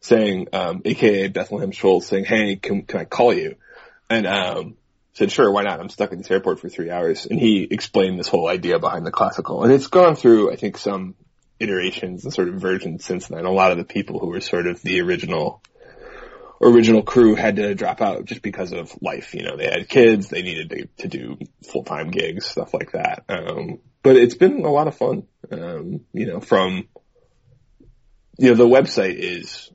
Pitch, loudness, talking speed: 120 Hz, -19 LUFS, 210 wpm